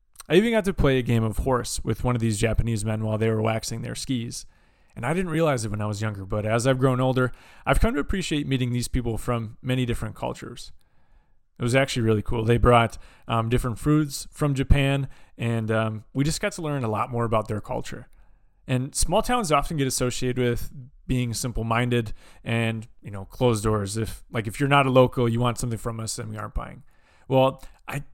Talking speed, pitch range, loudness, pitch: 220 wpm, 110-135 Hz, -25 LUFS, 120 Hz